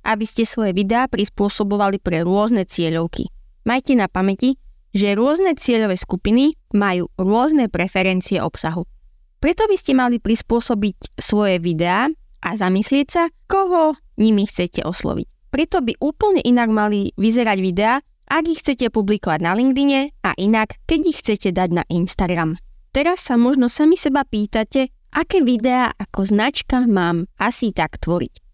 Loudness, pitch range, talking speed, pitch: -19 LUFS, 190-270 Hz, 145 wpm, 220 Hz